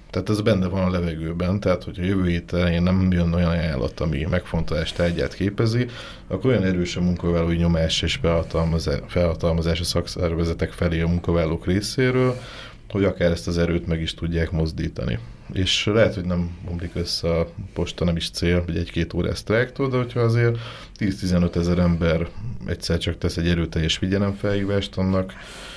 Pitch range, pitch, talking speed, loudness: 85-100 Hz, 85 Hz, 160 wpm, -23 LUFS